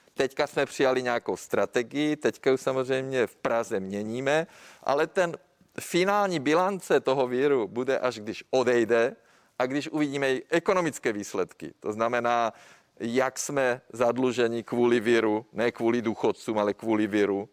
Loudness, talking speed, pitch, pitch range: -27 LUFS, 135 wpm, 125 Hz, 115-140 Hz